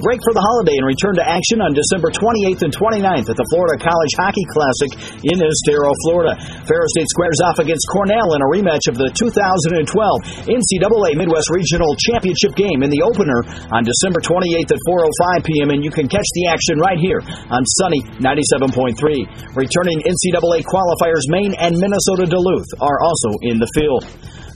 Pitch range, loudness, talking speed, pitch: 150-190 Hz, -15 LUFS, 175 wpm, 170 Hz